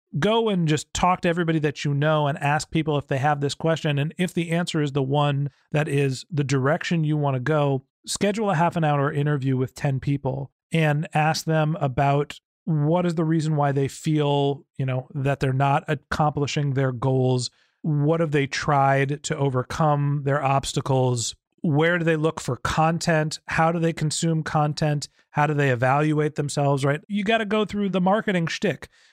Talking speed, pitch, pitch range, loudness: 190 wpm, 150 Hz, 140-165 Hz, -23 LUFS